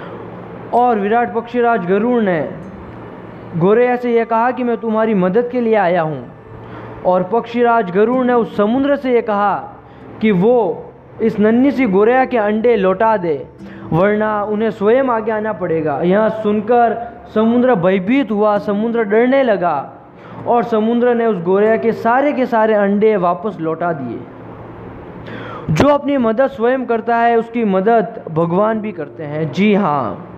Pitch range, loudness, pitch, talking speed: 200-235 Hz, -15 LUFS, 220 Hz, 150 wpm